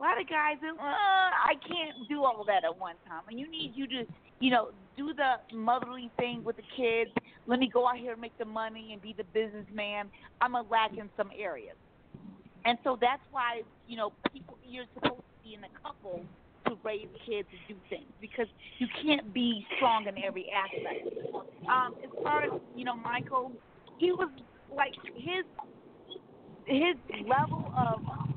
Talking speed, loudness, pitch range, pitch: 190 wpm, -32 LUFS, 220-280 Hz, 240 Hz